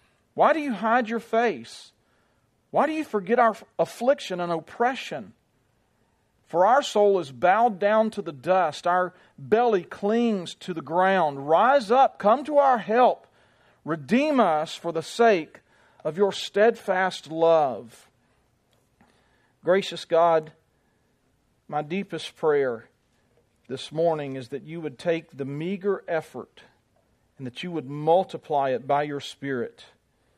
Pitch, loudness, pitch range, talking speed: 175 Hz, -24 LUFS, 150-220 Hz, 135 wpm